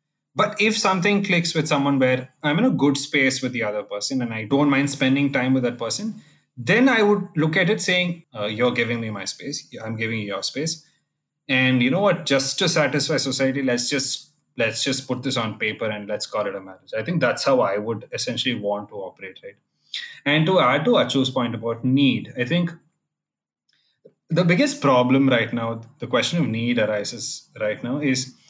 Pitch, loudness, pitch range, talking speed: 135 Hz, -21 LUFS, 120-160 Hz, 210 wpm